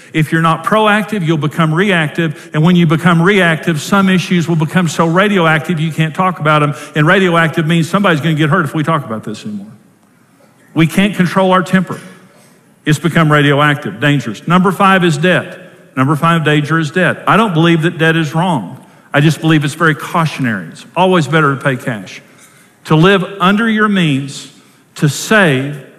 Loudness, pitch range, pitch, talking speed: -12 LUFS, 155-185 Hz, 165 Hz, 185 wpm